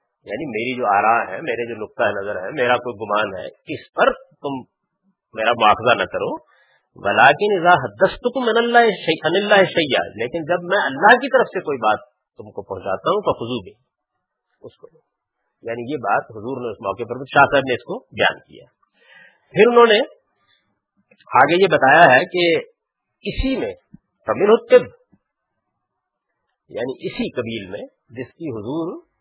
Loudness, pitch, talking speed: -17 LUFS, 180 Hz, 145 wpm